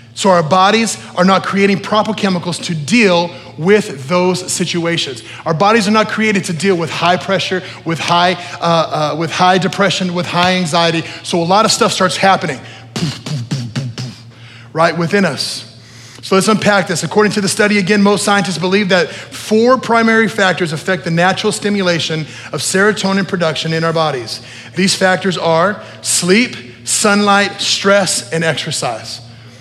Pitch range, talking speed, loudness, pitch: 155-195 Hz, 170 wpm, -13 LUFS, 180 Hz